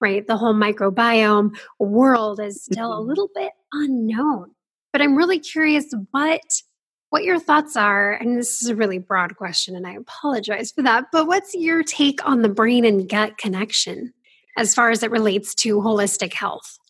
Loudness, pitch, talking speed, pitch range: -19 LUFS, 230 Hz, 180 wpm, 210-290 Hz